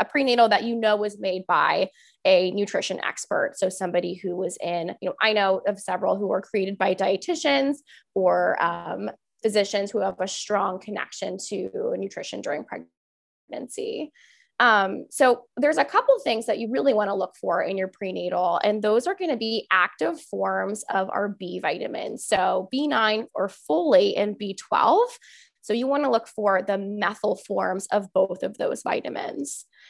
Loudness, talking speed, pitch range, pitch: -24 LUFS, 175 wpm, 190-255 Hz, 205 Hz